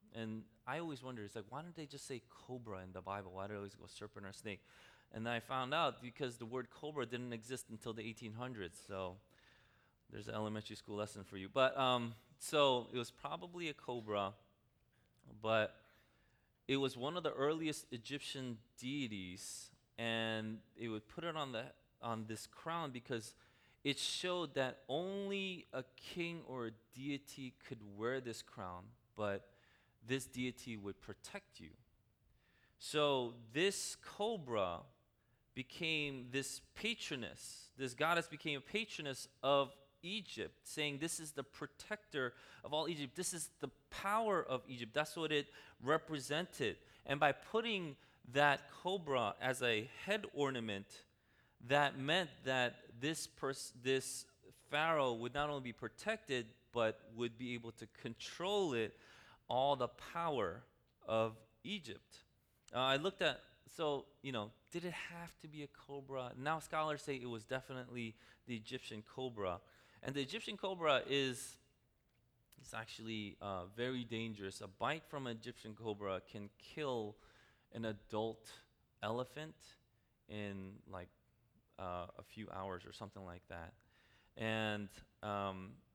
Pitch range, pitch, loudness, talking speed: 110-145 Hz, 125 Hz, -42 LUFS, 150 wpm